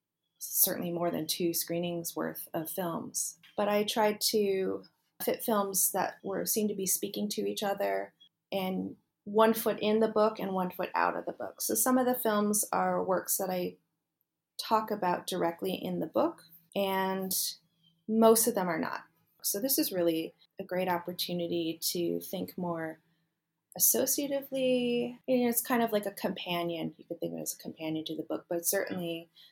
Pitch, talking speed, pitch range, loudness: 180 Hz, 180 wpm, 165-210 Hz, -31 LUFS